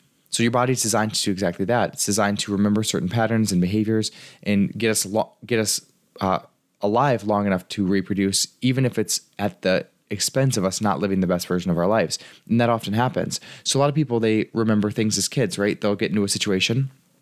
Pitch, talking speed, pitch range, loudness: 110 Hz, 225 wpm, 100-115 Hz, -22 LUFS